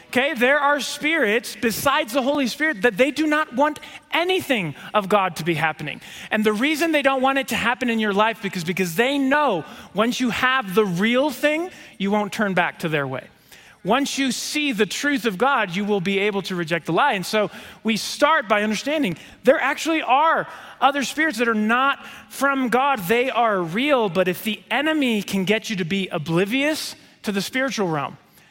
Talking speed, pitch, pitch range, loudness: 200 wpm, 235 Hz, 205-275 Hz, -21 LUFS